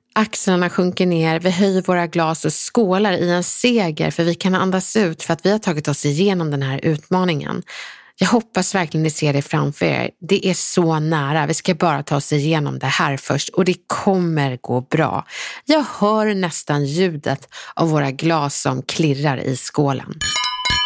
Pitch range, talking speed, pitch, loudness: 150-185 Hz, 185 wpm, 170 Hz, -19 LUFS